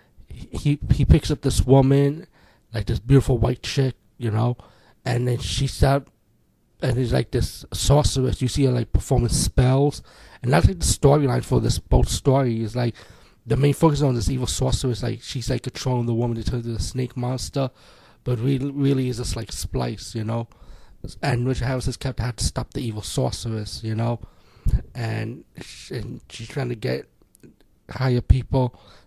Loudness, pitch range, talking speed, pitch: -23 LUFS, 110-130 Hz, 180 wpm, 125 Hz